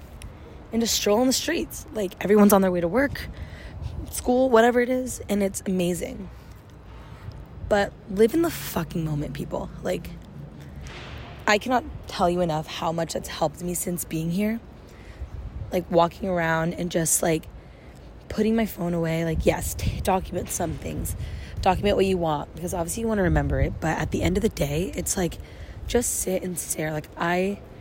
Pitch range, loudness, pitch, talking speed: 165-210 Hz, -25 LUFS, 180 Hz, 175 wpm